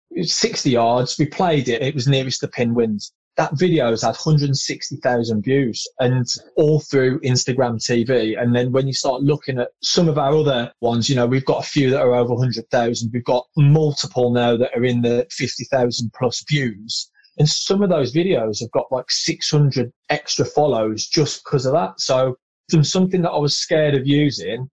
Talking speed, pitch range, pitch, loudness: 190 wpm, 120-150 Hz, 130 Hz, -19 LUFS